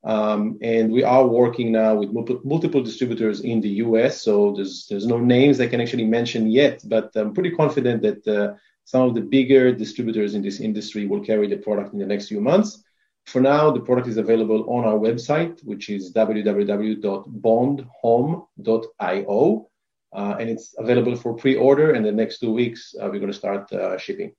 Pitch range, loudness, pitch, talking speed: 105-125 Hz, -21 LUFS, 115 Hz, 185 wpm